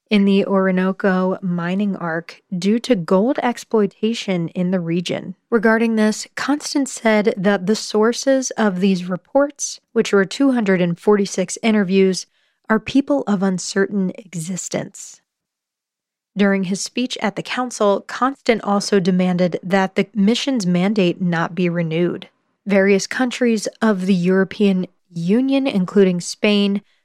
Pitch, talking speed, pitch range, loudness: 200 Hz, 120 wpm, 185-225 Hz, -18 LUFS